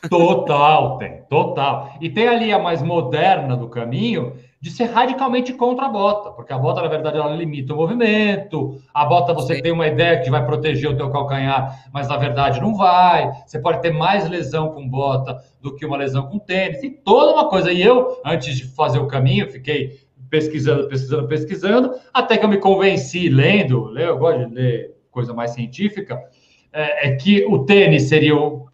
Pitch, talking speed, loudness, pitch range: 155 Hz, 190 wpm, -17 LUFS, 140-190 Hz